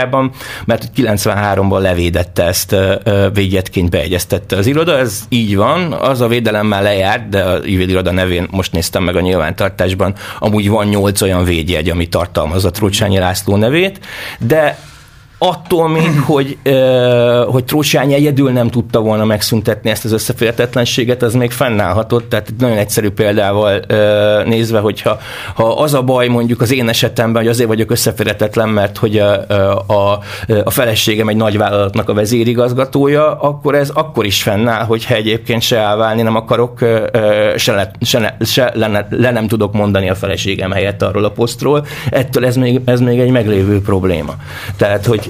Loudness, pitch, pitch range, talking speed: -13 LUFS, 110 Hz, 100-120 Hz, 160 wpm